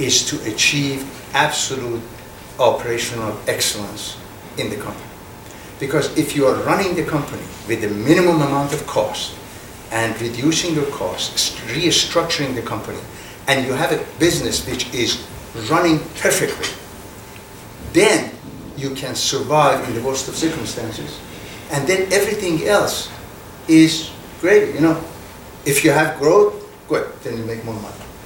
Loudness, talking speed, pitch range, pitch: -18 LUFS, 140 wpm, 105-150 Hz, 125 Hz